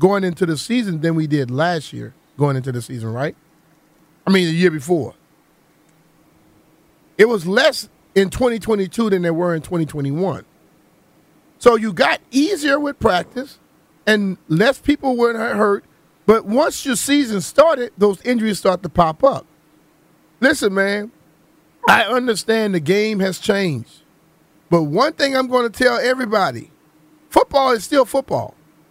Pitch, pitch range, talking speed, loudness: 195 Hz, 160-240 Hz, 145 wpm, -17 LUFS